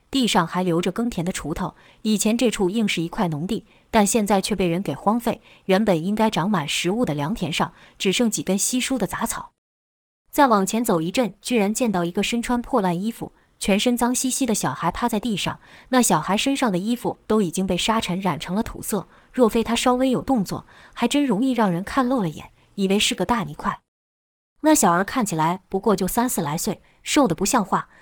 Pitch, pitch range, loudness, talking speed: 210 Hz, 180-240 Hz, -22 LUFS, 305 characters per minute